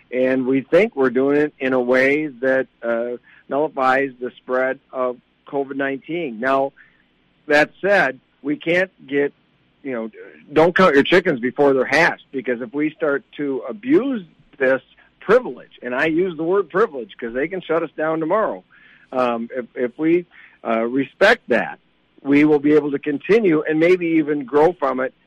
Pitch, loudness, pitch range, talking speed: 140 Hz, -19 LUFS, 130-155 Hz, 170 wpm